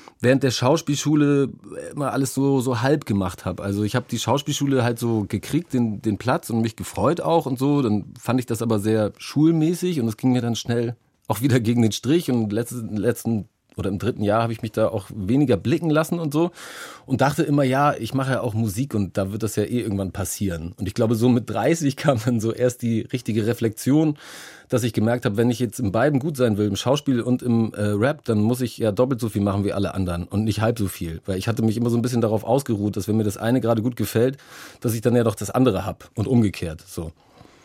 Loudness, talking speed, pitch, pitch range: -22 LUFS, 245 wpm, 120 Hz, 105-130 Hz